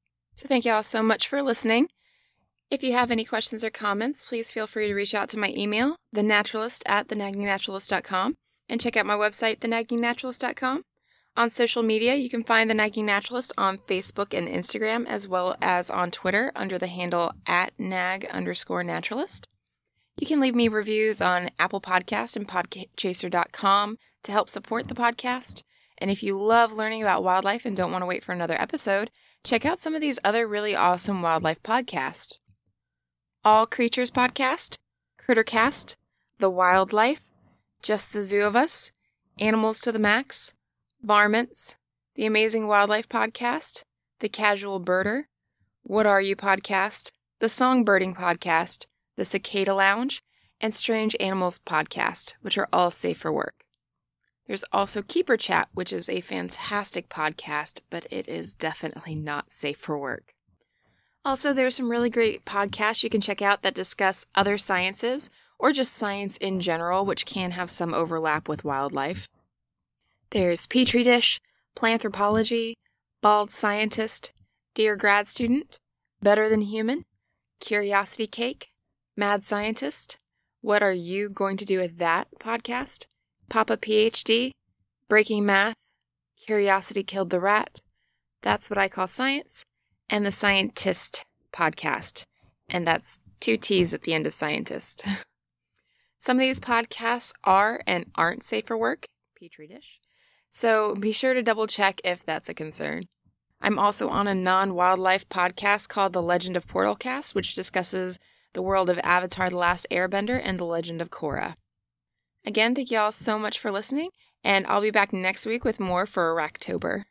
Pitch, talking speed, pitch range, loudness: 205 Hz, 155 wpm, 185-230 Hz, -24 LUFS